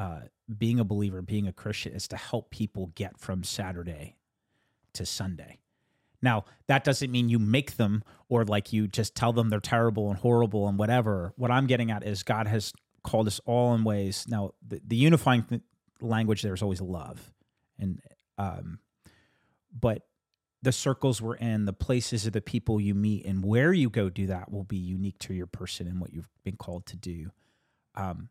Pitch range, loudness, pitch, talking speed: 95-120 Hz, -29 LUFS, 105 Hz, 190 wpm